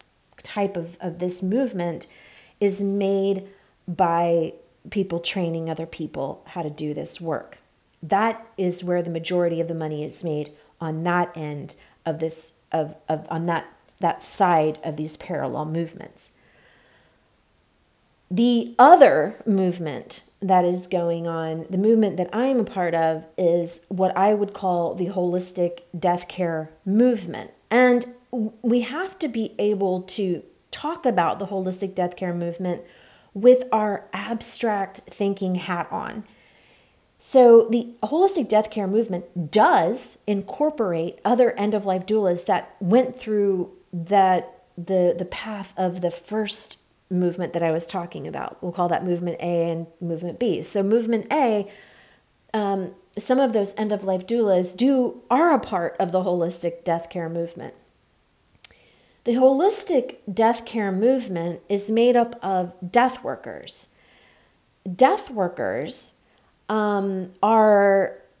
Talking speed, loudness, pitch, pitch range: 135 wpm, -21 LUFS, 185 Hz, 170-215 Hz